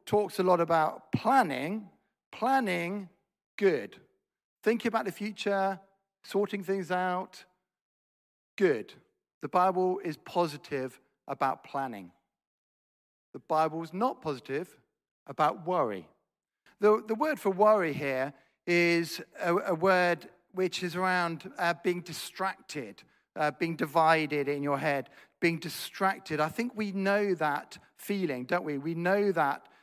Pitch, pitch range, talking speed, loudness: 180 Hz, 165-200 Hz, 125 wpm, -30 LUFS